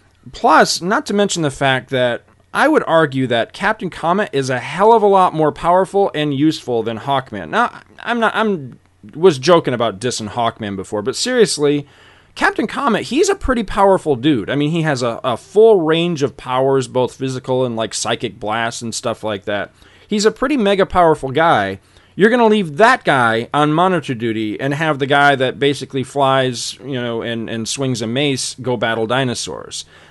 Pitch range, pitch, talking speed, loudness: 120-180 Hz, 135 Hz, 185 wpm, -16 LUFS